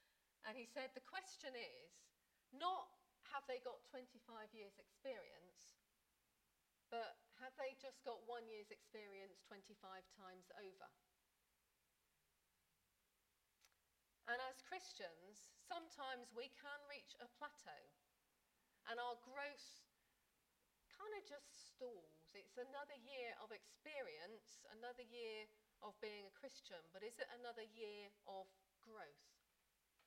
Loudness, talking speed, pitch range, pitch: -55 LUFS, 115 wpm, 215-285 Hz, 245 Hz